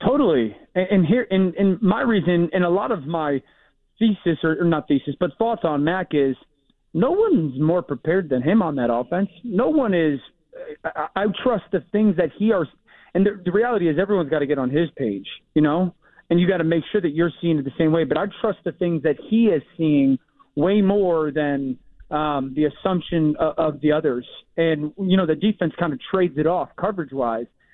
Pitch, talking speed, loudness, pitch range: 170 Hz, 215 wpm, -21 LUFS, 150-195 Hz